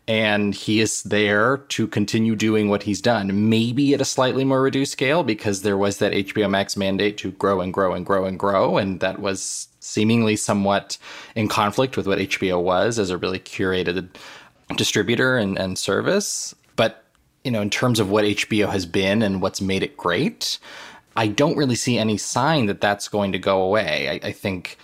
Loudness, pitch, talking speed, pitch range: -21 LUFS, 105 Hz, 200 wpm, 100-115 Hz